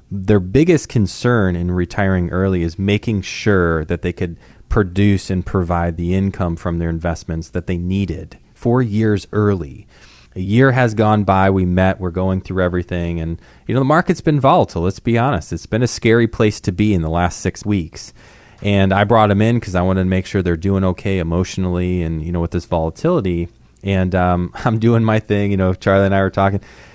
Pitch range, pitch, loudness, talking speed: 90-105 Hz, 95 Hz, -17 LUFS, 205 wpm